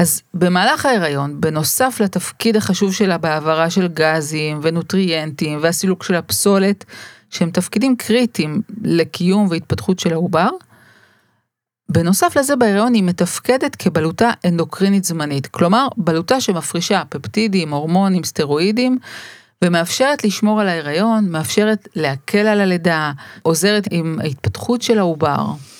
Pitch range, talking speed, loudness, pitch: 160-215 Hz, 110 wpm, -17 LUFS, 180 Hz